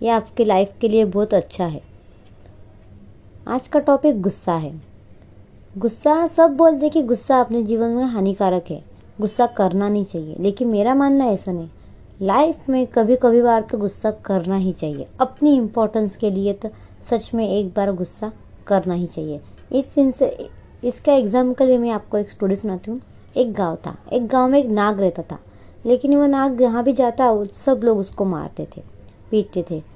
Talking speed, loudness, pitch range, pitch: 180 wpm, -19 LUFS, 185-255 Hz, 215 Hz